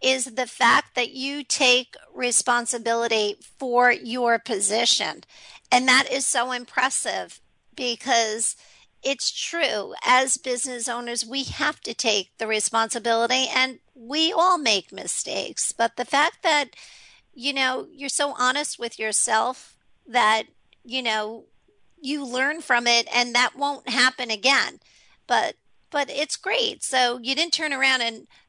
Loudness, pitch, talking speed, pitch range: -22 LUFS, 250 Hz, 135 wpm, 235-275 Hz